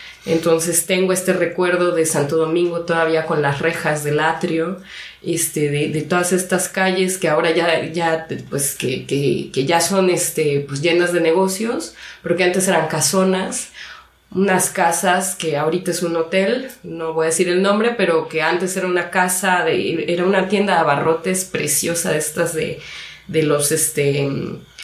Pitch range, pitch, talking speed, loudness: 160-185 Hz, 170 Hz, 170 wpm, -18 LUFS